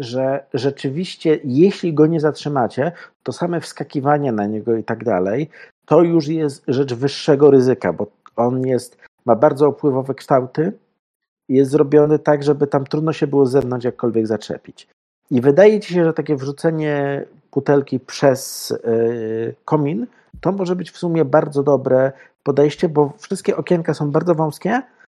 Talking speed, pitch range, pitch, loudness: 155 wpm, 130-160 Hz, 145 Hz, -18 LUFS